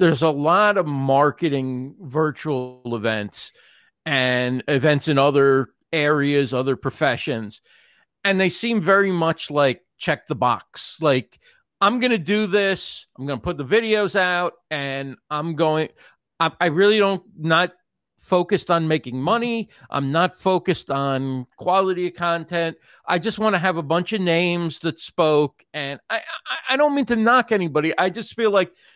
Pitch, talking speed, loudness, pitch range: 165 Hz, 160 wpm, -21 LUFS, 140-190 Hz